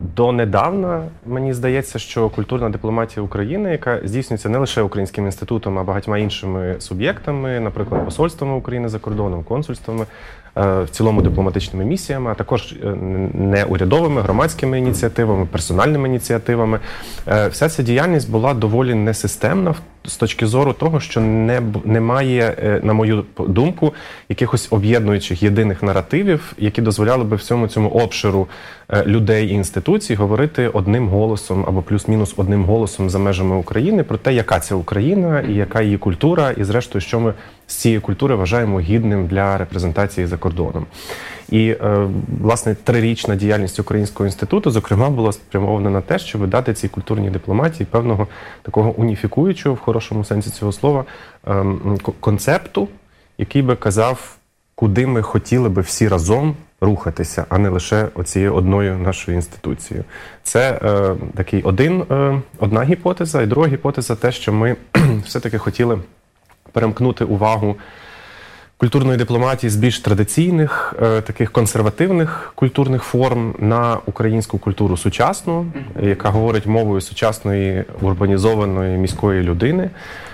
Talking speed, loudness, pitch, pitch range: 130 wpm, -18 LUFS, 110 Hz, 100-125 Hz